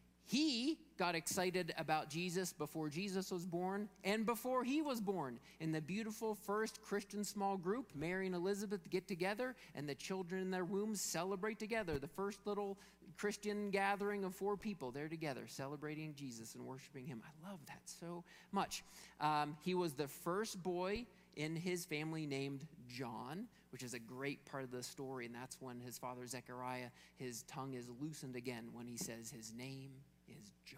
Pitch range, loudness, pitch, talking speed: 135-200 Hz, -44 LUFS, 170 Hz, 175 wpm